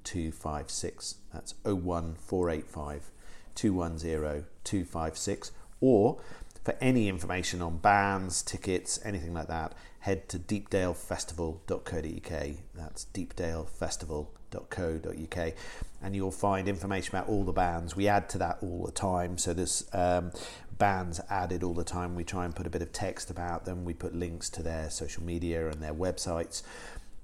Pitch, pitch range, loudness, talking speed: 90 Hz, 80-95 Hz, -33 LUFS, 160 wpm